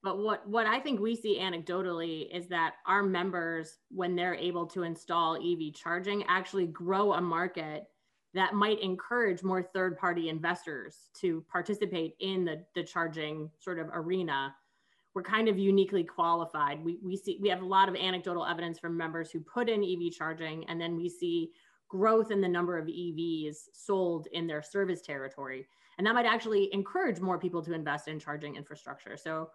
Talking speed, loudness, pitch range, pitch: 180 wpm, -32 LUFS, 165-190 Hz, 175 Hz